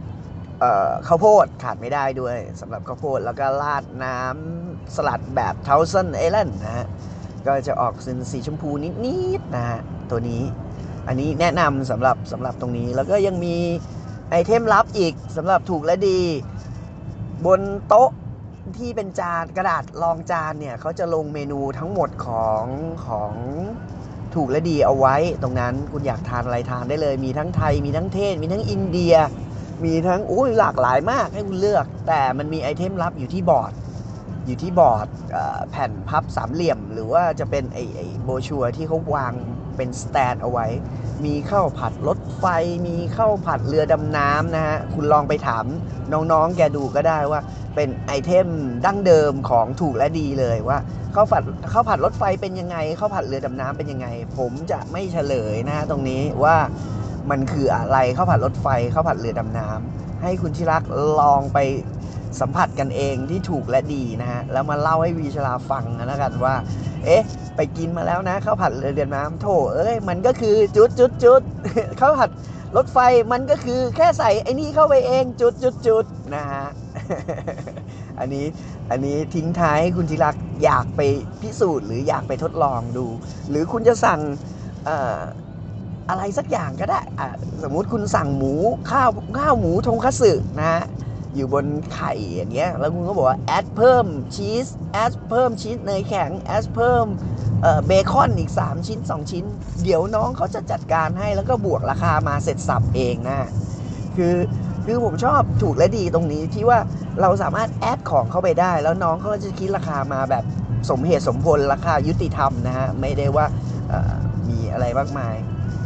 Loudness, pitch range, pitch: -21 LUFS, 125-165 Hz, 140 Hz